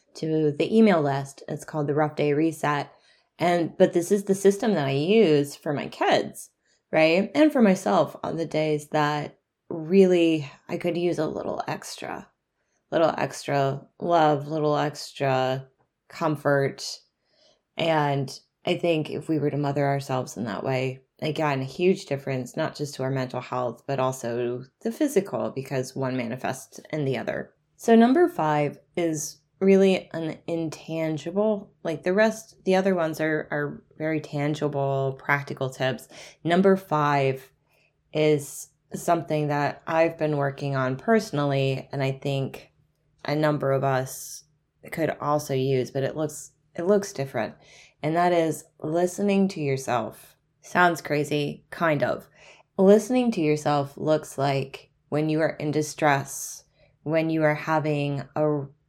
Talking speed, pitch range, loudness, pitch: 150 wpm, 140-165 Hz, -25 LUFS, 150 Hz